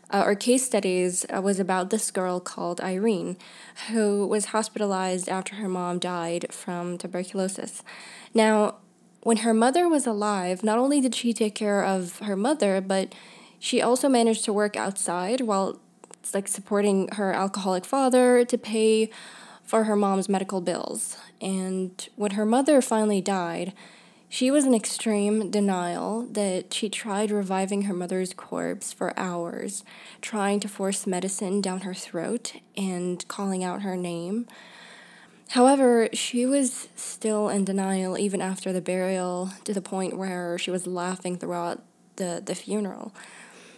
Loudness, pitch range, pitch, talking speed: -25 LUFS, 185-225 Hz, 200 Hz, 150 wpm